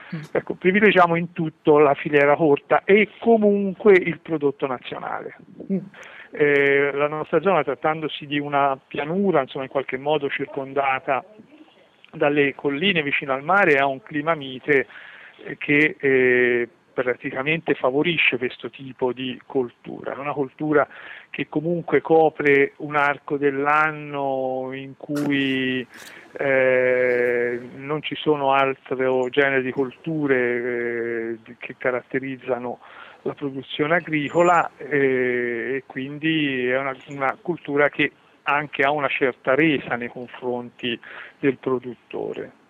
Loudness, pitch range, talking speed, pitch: -21 LUFS, 130-155 Hz, 120 wpm, 140 Hz